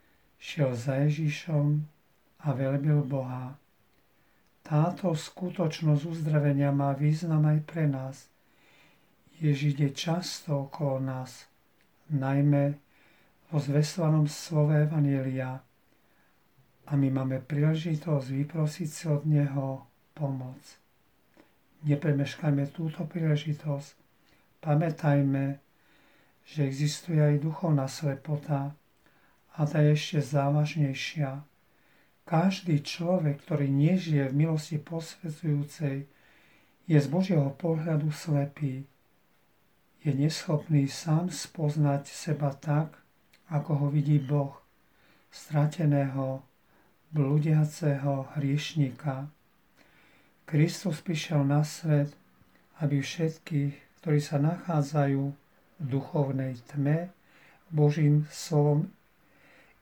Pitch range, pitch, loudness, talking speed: 140-155 Hz, 150 Hz, -29 LUFS, 85 wpm